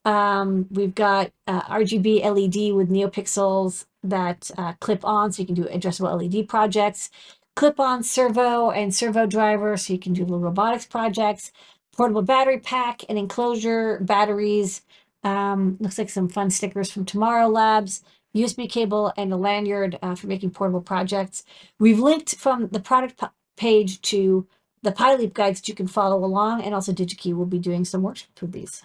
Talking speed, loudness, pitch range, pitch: 175 wpm, -22 LUFS, 190-220 Hz, 205 Hz